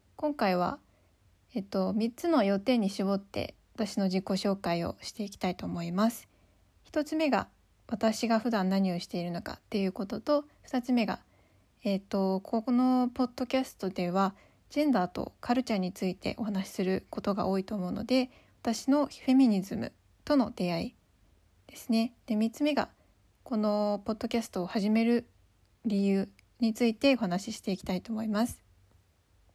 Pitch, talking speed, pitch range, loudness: 215 Hz, 315 characters per minute, 190-235 Hz, -31 LUFS